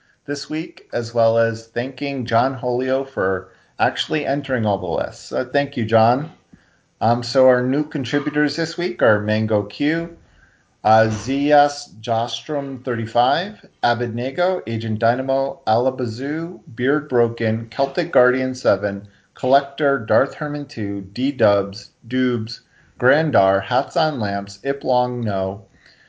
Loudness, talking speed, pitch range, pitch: -20 LUFS, 125 wpm, 110-140 Hz, 125 Hz